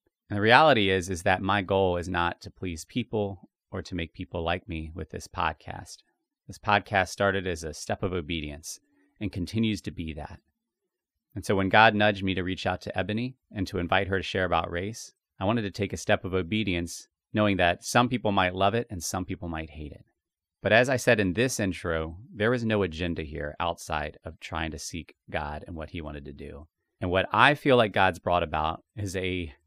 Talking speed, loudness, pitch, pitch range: 220 wpm, -27 LUFS, 95 Hz, 85-105 Hz